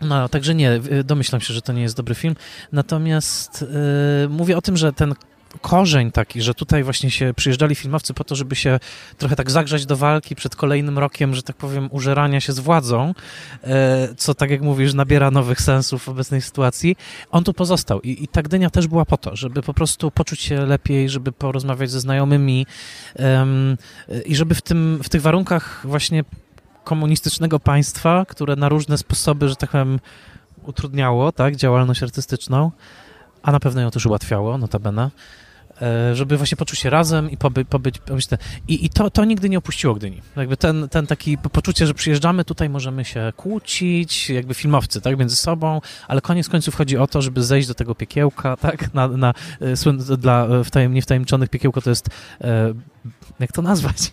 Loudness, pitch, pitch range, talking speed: -19 LUFS, 140 Hz, 130-155 Hz, 180 wpm